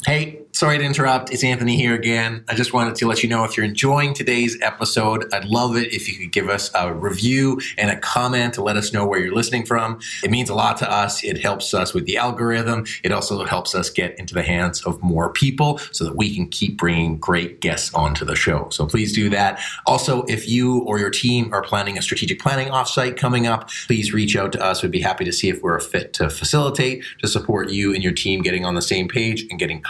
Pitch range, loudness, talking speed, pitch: 100-125 Hz, -20 LUFS, 245 wpm, 115 Hz